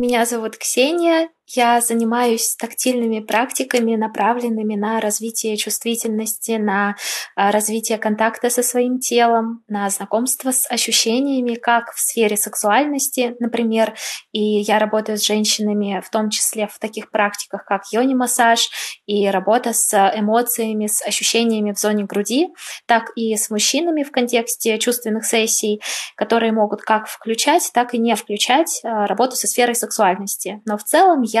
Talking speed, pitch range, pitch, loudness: 140 wpm, 210-240 Hz, 225 Hz, -18 LUFS